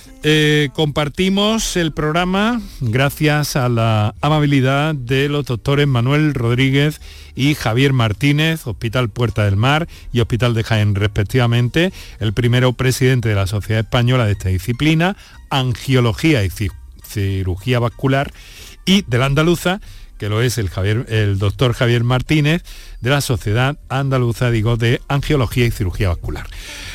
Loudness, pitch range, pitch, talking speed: -17 LUFS, 110-145 Hz, 125 Hz, 140 wpm